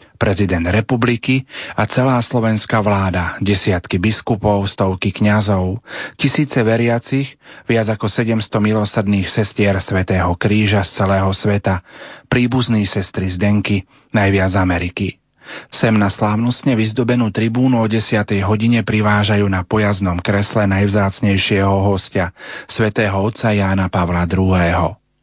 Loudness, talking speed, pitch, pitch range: -16 LUFS, 110 wpm, 105 Hz, 95-115 Hz